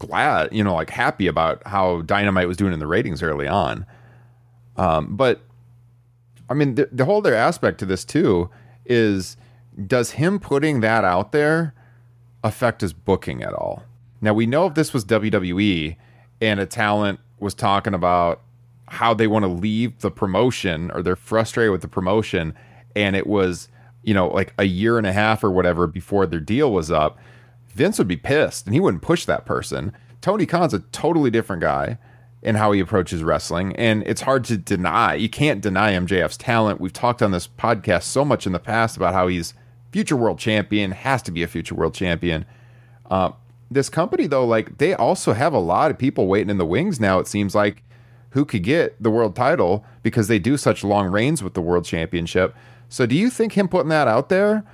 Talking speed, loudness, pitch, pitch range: 200 wpm, -20 LUFS, 110 Hz, 95-120 Hz